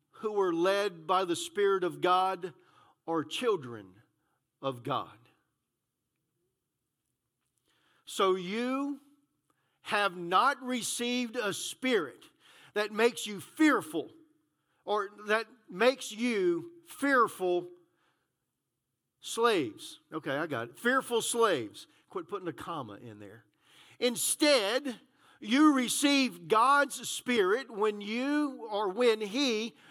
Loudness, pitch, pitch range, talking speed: -30 LUFS, 220 Hz, 175-260 Hz, 100 wpm